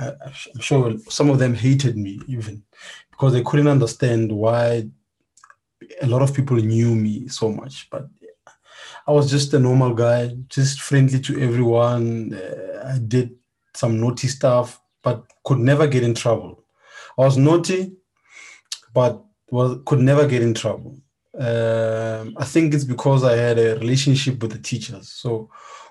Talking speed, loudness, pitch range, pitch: 155 wpm, -19 LUFS, 115-140 Hz, 125 Hz